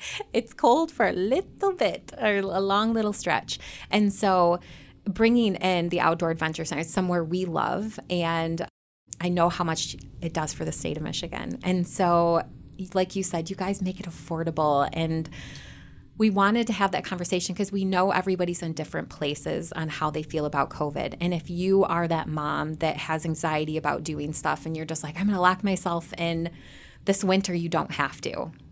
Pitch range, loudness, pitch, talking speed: 160-190 Hz, -26 LUFS, 175 Hz, 190 wpm